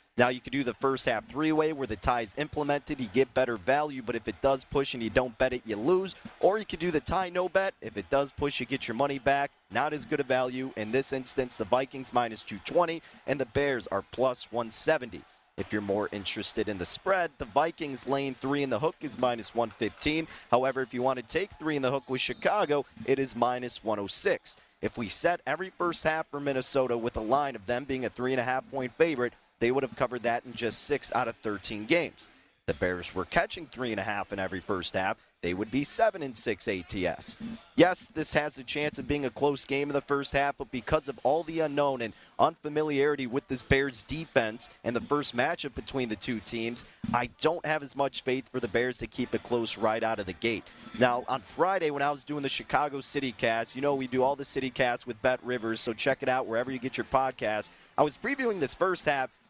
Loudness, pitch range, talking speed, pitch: -30 LUFS, 120-145 Hz, 240 wpm, 130 Hz